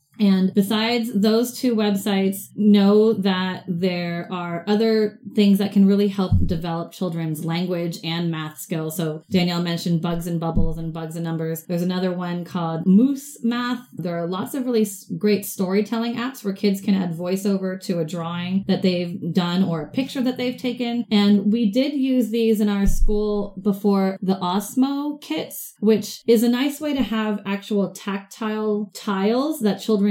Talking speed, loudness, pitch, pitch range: 170 wpm, -22 LUFS, 200 Hz, 180-220 Hz